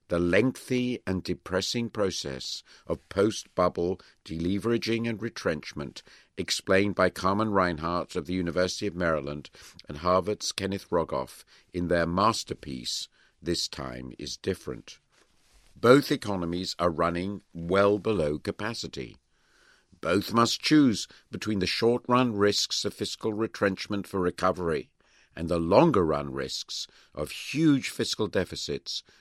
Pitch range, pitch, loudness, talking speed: 85-110 Hz, 95 Hz, -28 LUFS, 125 wpm